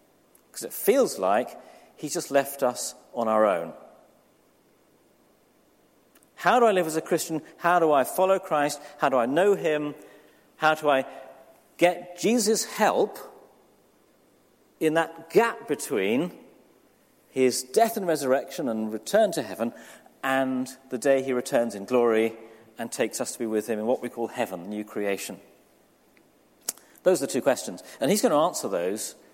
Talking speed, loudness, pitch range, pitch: 160 wpm, -25 LUFS, 120-165 Hz, 135 Hz